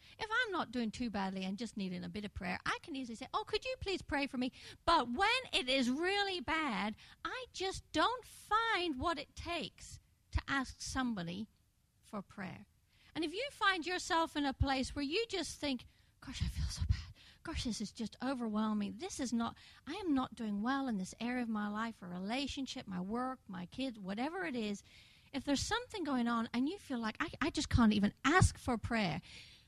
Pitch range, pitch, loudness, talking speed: 220-335 Hz, 265 Hz, -37 LUFS, 210 wpm